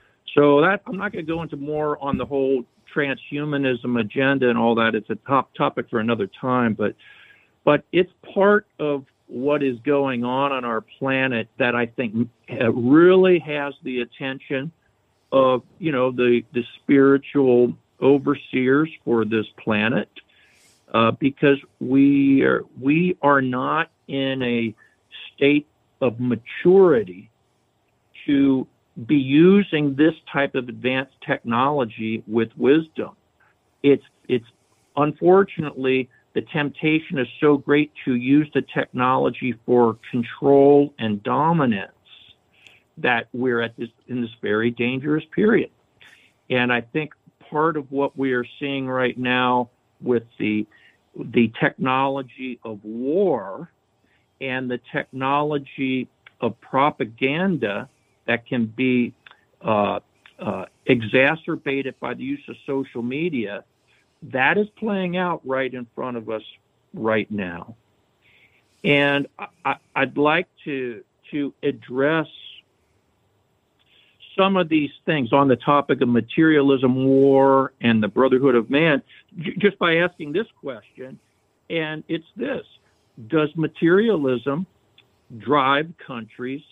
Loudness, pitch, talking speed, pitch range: -21 LUFS, 135 Hz, 125 wpm, 120-150 Hz